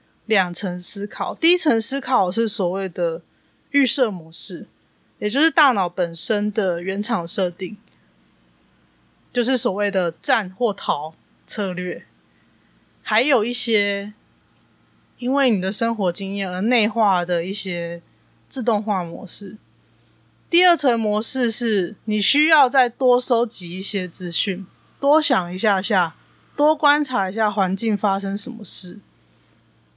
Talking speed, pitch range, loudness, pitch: 190 characters per minute, 180-240 Hz, -20 LUFS, 205 Hz